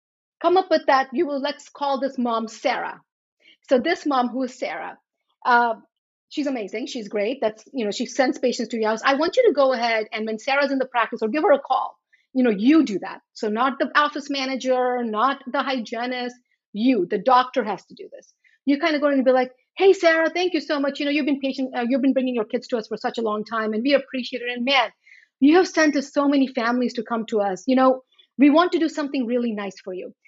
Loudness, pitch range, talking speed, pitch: -22 LUFS, 235-290 Hz, 250 wpm, 260 Hz